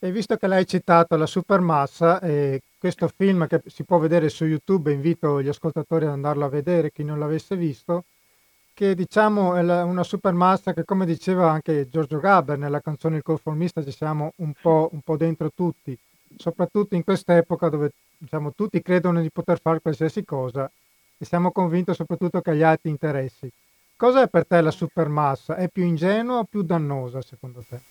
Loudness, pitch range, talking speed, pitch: -22 LUFS, 150-180 Hz, 185 wpm, 165 Hz